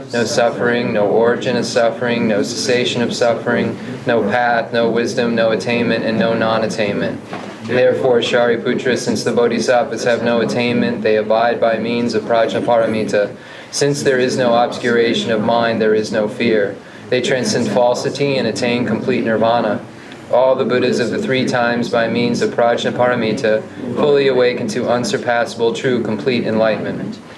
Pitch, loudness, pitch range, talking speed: 120 Hz, -16 LUFS, 110-120 Hz, 155 wpm